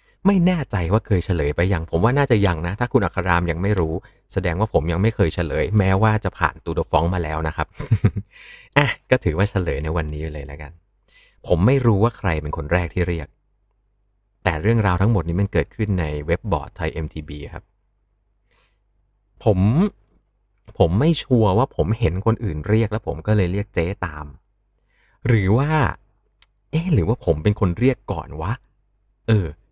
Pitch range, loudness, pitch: 85-110 Hz, -21 LUFS, 100 Hz